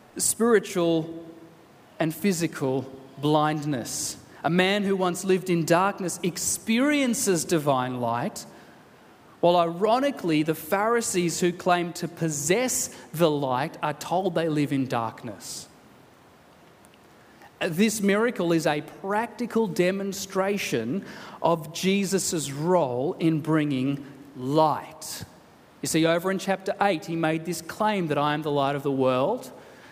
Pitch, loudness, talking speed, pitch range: 170 Hz, -25 LUFS, 120 wpm, 150-190 Hz